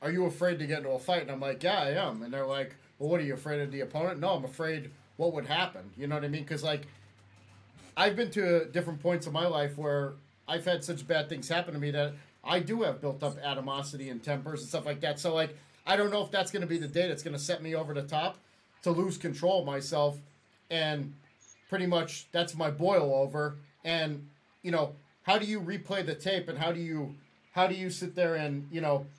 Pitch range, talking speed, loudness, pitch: 145-175 Hz, 250 wpm, -32 LUFS, 155 Hz